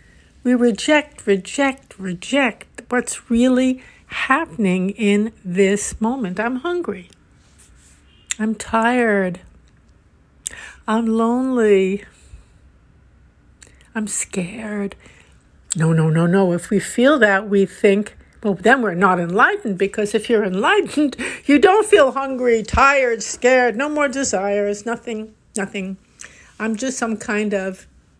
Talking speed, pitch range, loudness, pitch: 115 wpm, 195-245 Hz, -18 LUFS, 215 Hz